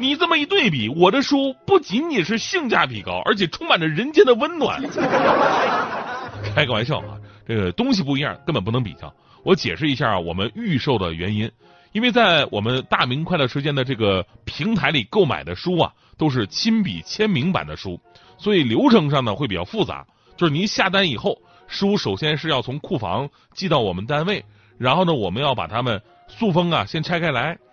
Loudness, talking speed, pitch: -20 LUFS, 295 characters per minute, 150 Hz